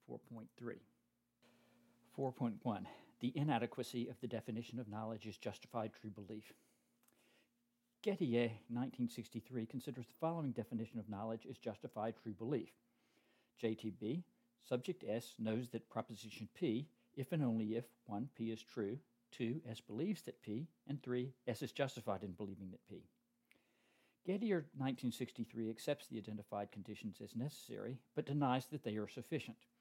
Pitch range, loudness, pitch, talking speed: 110-135 Hz, -45 LUFS, 120 Hz, 135 wpm